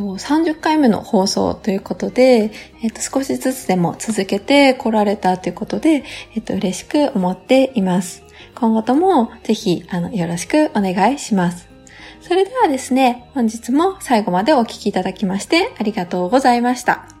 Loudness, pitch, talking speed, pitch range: -17 LUFS, 225 Hz, 340 characters per minute, 190-265 Hz